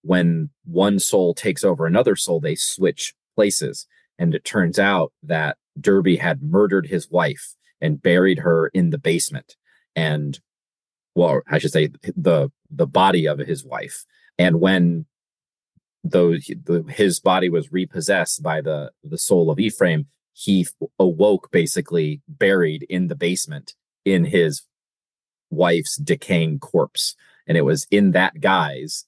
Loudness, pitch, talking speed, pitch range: -20 LUFS, 90 Hz, 140 wpm, 85-125 Hz